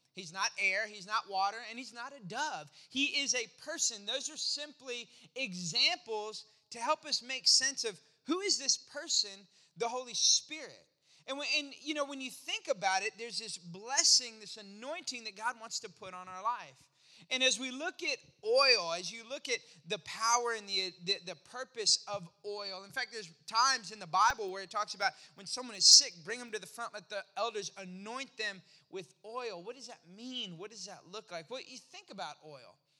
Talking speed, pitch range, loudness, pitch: 210 wpm, 200-265 Hz, -32 LUFS, 230 Hz